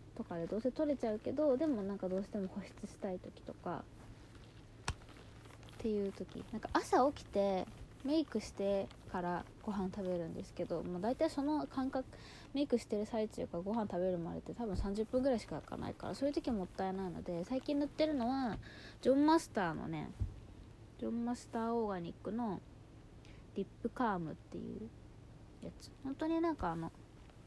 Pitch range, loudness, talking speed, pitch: 175-260 Hz, -39 LUFS, 360 characters per minute, 210 Hz